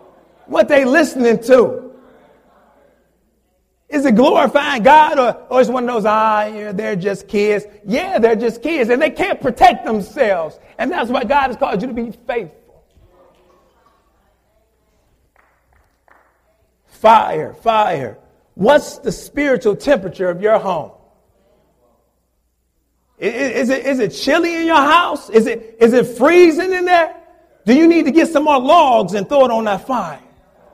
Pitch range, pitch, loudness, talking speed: 210-295 Hz, 255 Hz, -14 LUFS, 150 wpm